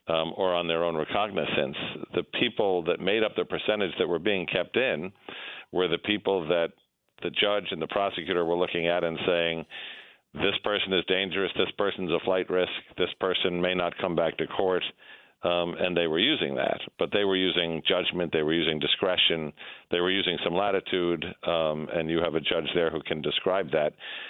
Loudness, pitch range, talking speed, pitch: -27 LUFS, 85-95 Hz, 200 wpm, 85 Hz